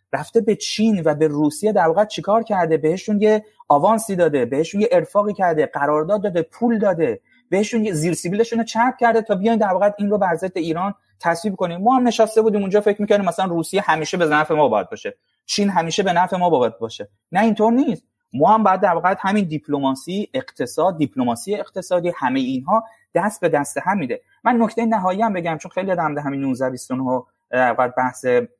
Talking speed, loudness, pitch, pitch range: 195 wpm, -19 LUFS, 195 Hz, 160-220 Hz